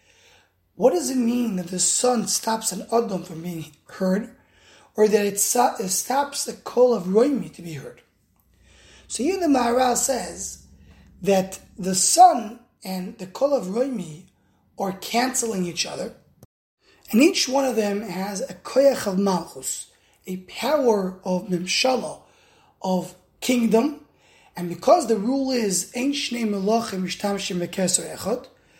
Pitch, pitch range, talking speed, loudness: 205 Hz, 180-250 Hz, 130 wpm, -22 LUFS